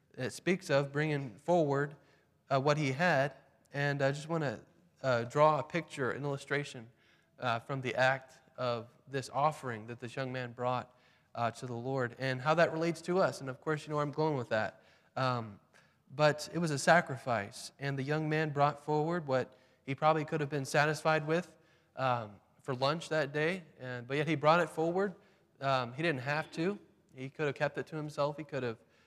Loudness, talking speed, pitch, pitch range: -33 LUFS, 200 wpm, 145 Hz, 130-155 Hz